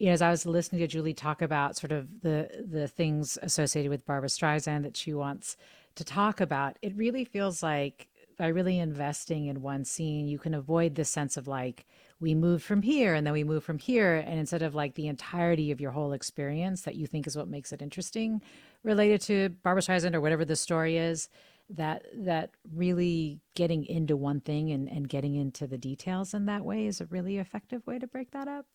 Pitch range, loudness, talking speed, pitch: 150-185 Hz, -31 LUFS, 215 wpm, 160 Hz